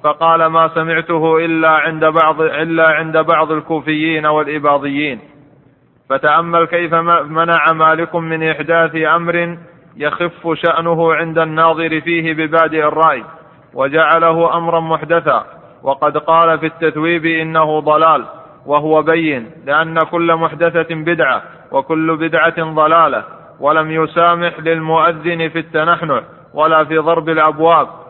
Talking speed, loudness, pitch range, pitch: 110 wpm, -13 LUFS, 155-165 Hz, 160 Hz